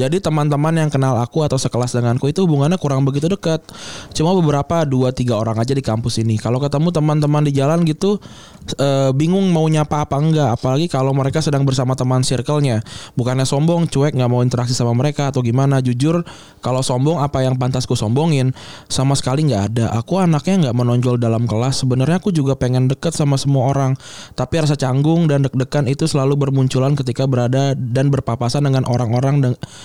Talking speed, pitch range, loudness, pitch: 185 wpm, 125-150 Hz, -17 LUFS, 135 Hz